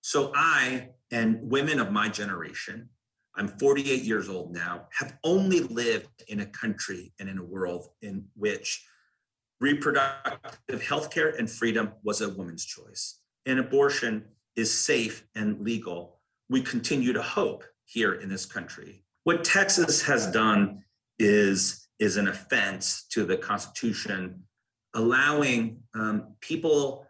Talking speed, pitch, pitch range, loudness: 135 wpm, 115 Hz, 100-135 Hz, -27 LUFS